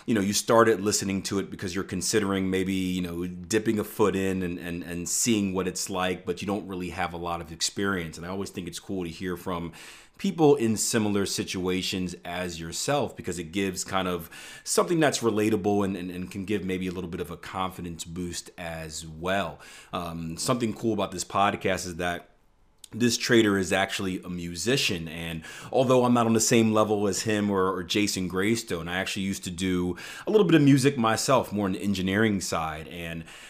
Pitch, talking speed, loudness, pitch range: 95 Hz, 210 wpm, -27 LUFS, 90-105 Hz